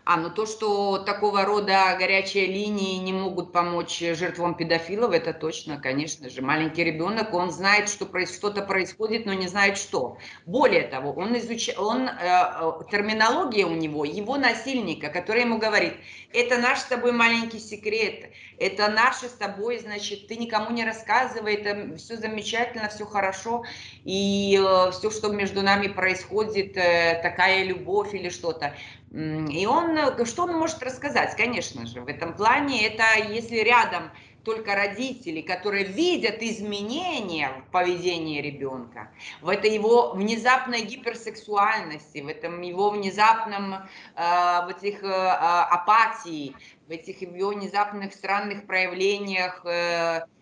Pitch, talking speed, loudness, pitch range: 200 Hz, 135 wpm, -24 LUFS, 175-220 Hz